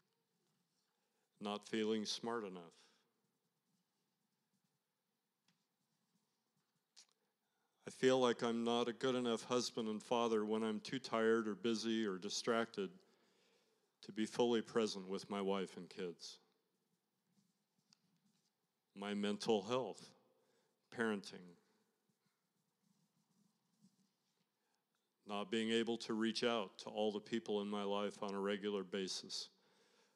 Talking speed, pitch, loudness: 105 wpm, 130 Hz, -41 LUFS